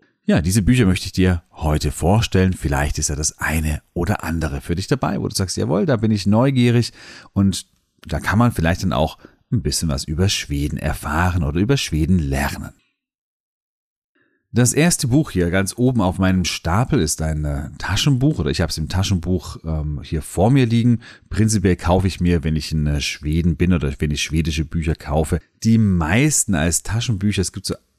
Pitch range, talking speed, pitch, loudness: 80-110 Hz, 190 wpm, 90 Hz, -19 LUFS